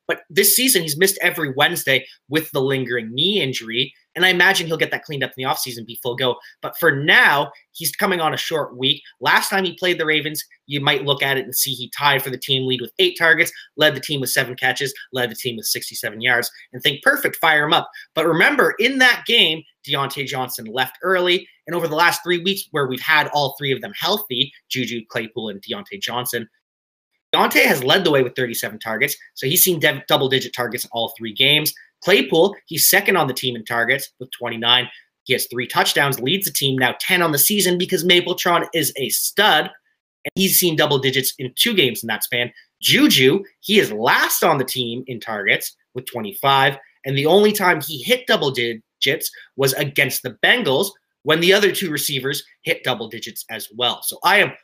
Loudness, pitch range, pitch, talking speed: -18 LUFS, 125-170 Hz, 140 Hz, 215 wpm